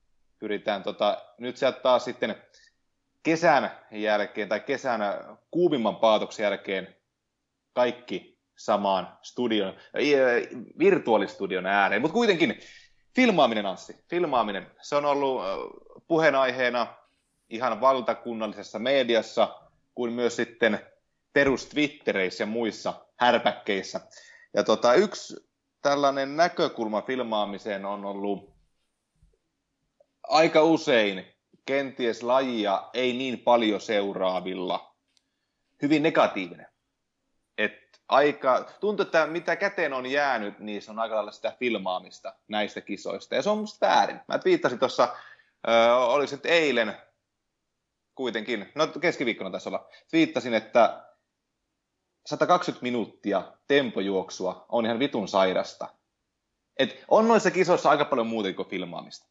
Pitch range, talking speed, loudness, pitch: 105-150 Hz, 110 wpm, -26 LUFS, 125 Hz